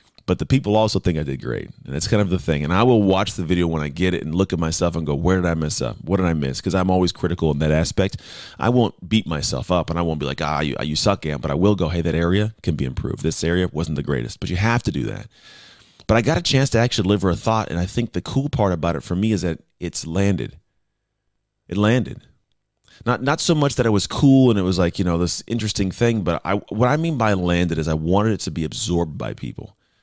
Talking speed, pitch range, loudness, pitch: 280 wpm, 85-110 Hz, -20 LUFS, 95 Hz